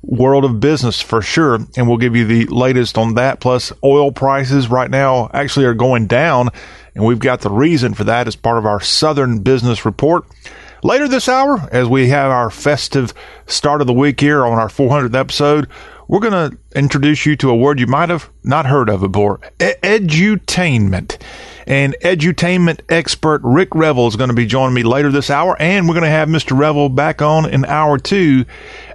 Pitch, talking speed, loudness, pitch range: 135 Hz, 200 wpm, -13 LUFS, 120-150 Hz